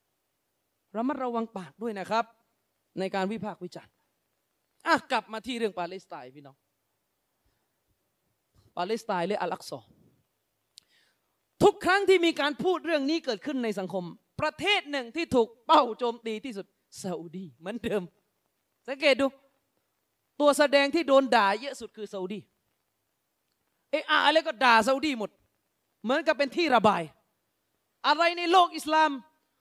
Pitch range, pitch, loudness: 205-300 Hz, 240 Hz, -26 LUFS